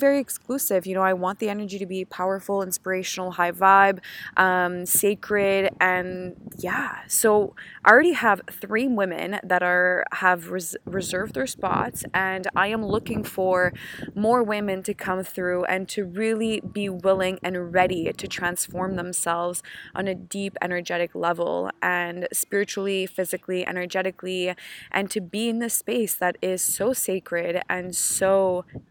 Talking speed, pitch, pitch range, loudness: 150 wpm, 190 Hz, 180-205 Hz, -24 LUFS